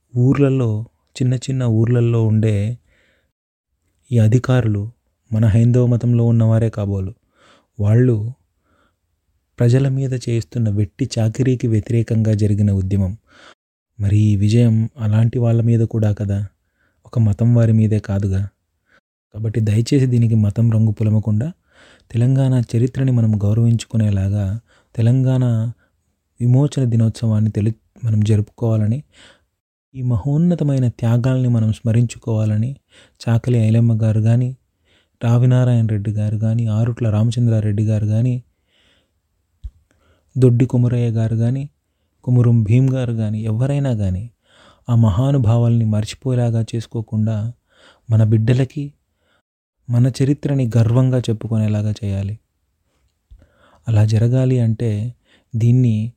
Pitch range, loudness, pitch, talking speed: 105-120 Hz, -17 LUFS, 115 Hz, 100 wpm